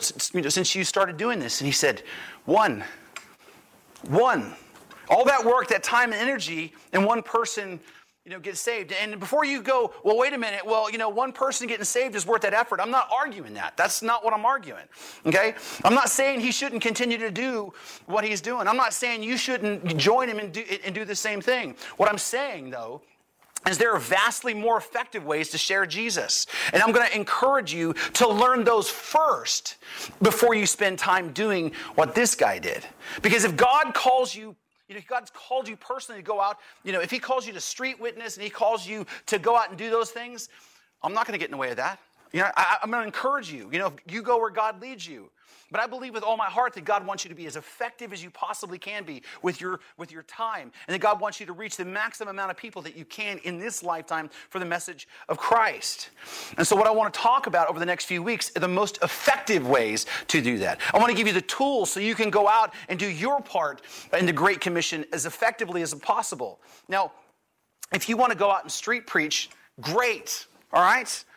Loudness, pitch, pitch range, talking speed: -25 LUFS, 215 Hz, 190-240 Hz, 235 wpm